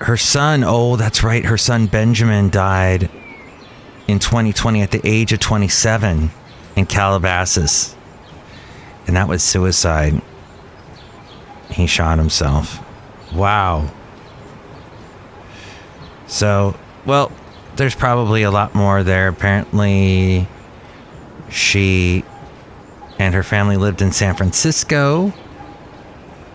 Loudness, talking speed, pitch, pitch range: -15 LUFS, 95 wpm, 100 Hz, 95-110 Hz